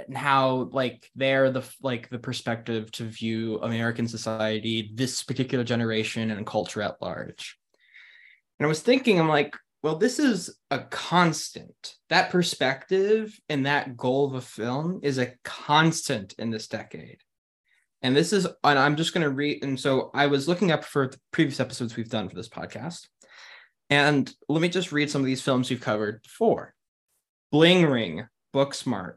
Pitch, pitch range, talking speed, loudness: 135 Hz, 115-150 Hz, 170 wpm, -25 LUFS